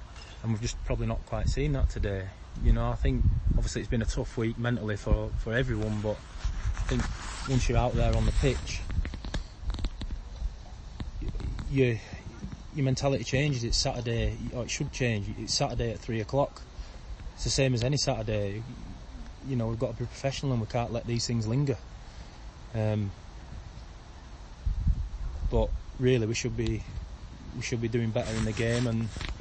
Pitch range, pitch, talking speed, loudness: 95-120 Hz, 115 Hz, 170 wpm, -31 LUFS